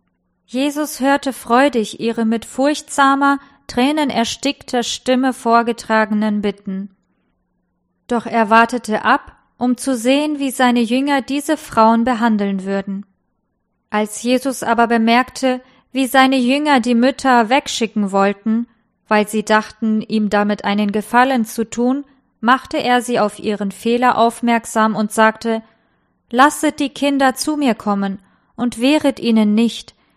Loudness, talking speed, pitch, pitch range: -16 LUFS, 125 wpm, 235 Hz, 220-265 Hz